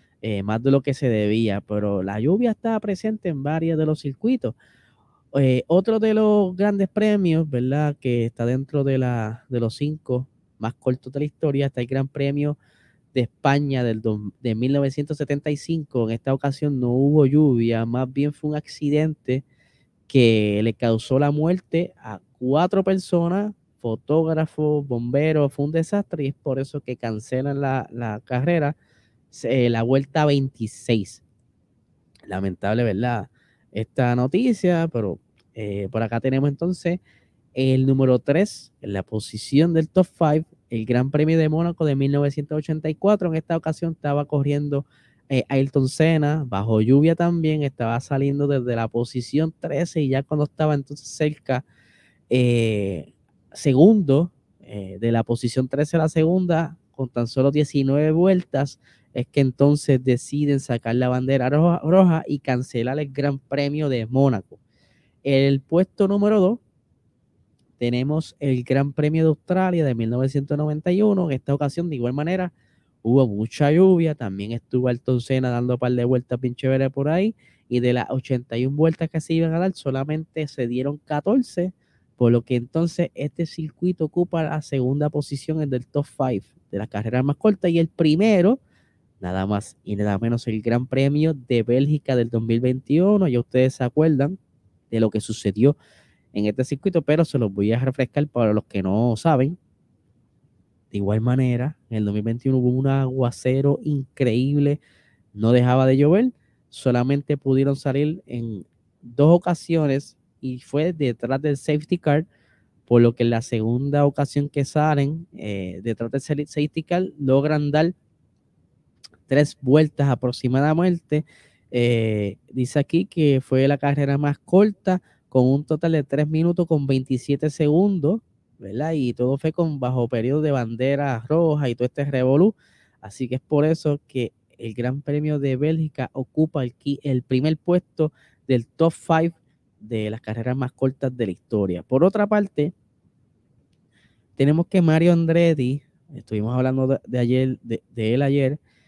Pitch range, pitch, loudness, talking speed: 120-155 Hz, 140 Hz, -22 LUFS, 155 wpm